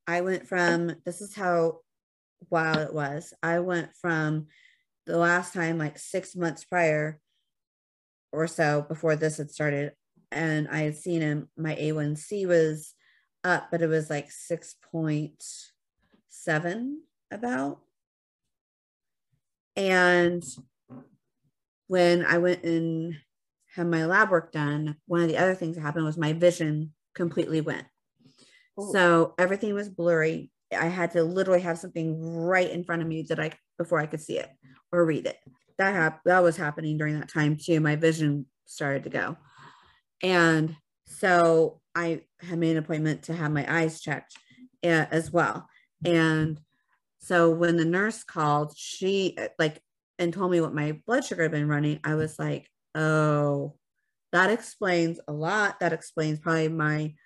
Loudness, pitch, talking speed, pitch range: -27 LUFS, 165 Hz, 155 wpm, 150-175 Hz